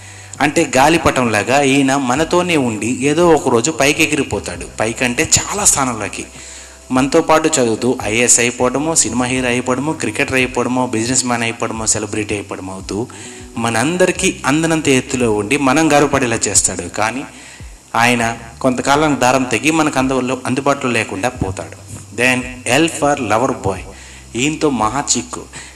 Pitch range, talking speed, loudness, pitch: 110-145 Hz, 125 wpm, -15 LUFS, 125 Hz